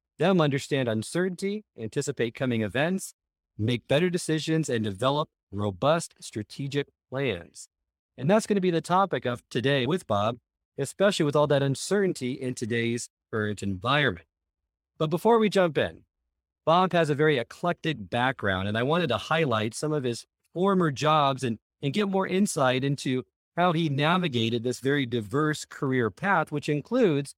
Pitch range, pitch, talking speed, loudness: 120-170 Hz, 140 Hz, 155 wpm, -26 LUFS